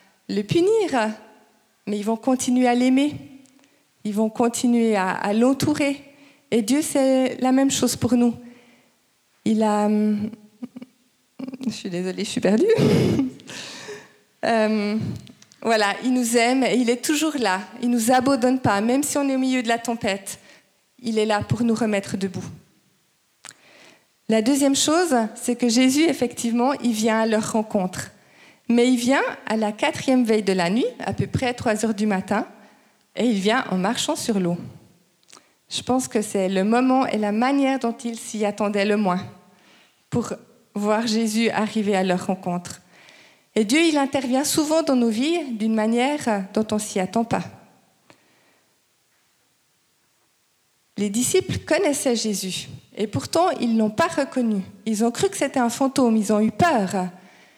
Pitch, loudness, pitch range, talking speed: 235 Hz, -21 LUFS, 210-260 Hz, 160 wpm